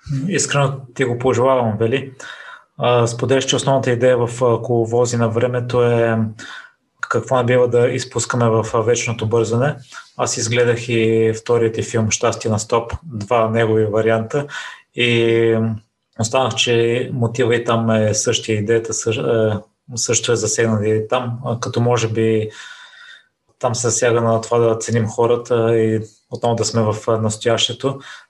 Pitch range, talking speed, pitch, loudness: 110-125 Hz, 135 wpm, 115 Hz, -17 LUFS